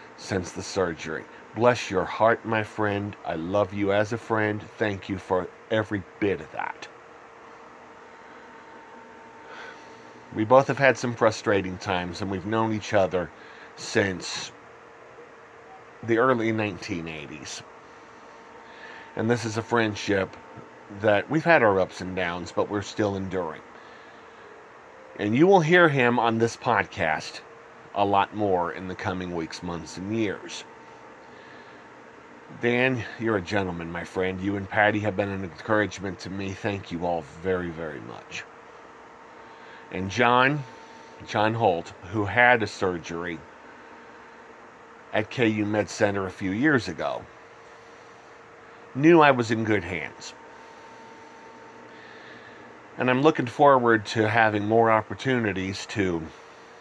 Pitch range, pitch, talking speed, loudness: 95-115 Hz, 105 Hz, 130 wpm, -25 LUFS